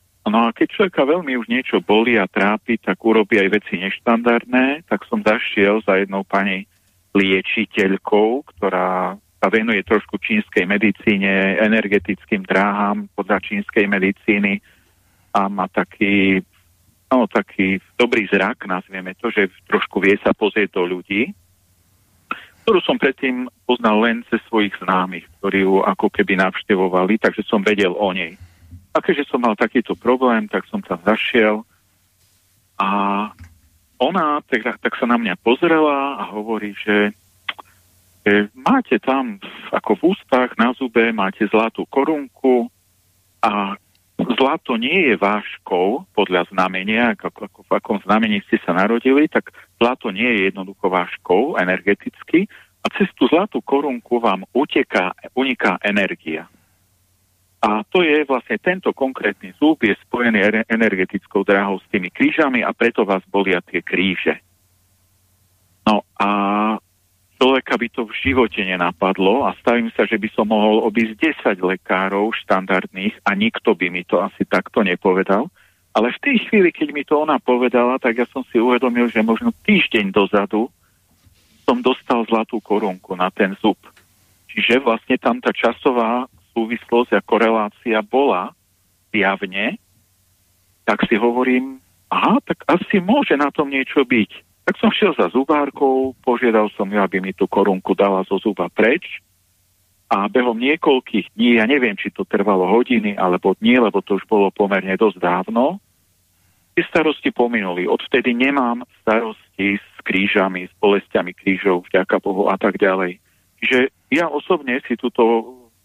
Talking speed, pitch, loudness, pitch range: 145 wpm, 105 Hz, -18 LUFS, 95-120 Hz